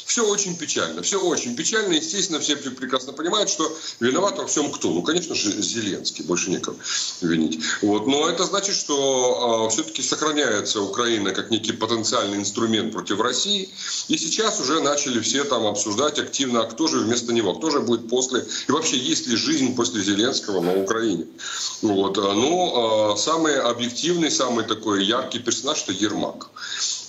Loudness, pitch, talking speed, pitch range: -22 LUFS, 135 Hz, 165 wpm, 115-165 Hz